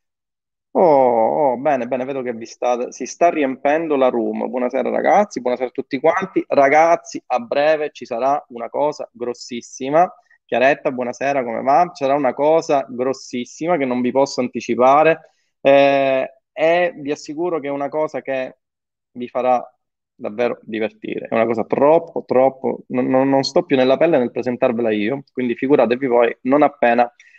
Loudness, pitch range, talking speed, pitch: -18 LUFS, 125-150 Hz, 160 wpm, 135 Hz